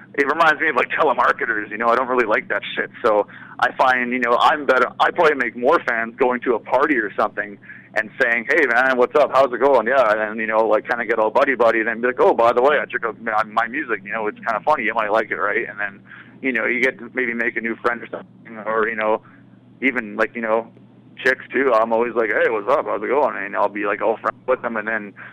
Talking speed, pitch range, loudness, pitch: 280 wpm, 110-125 Hz, -19 LUFS, 115 Hz